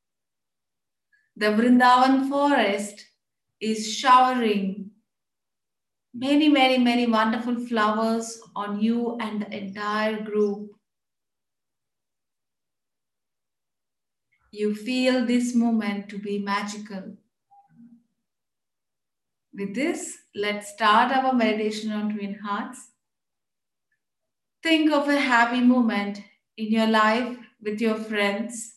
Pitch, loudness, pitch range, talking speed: 220 Hz, -23 LUFS, 210-245 Hz, 90 wpm